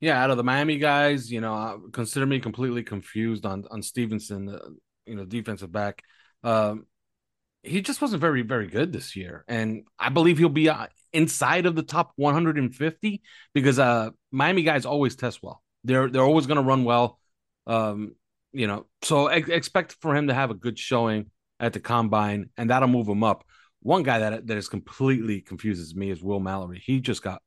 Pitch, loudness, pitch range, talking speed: 120 Hz, -25 LUFS, 105-145 Hz, 205 wpm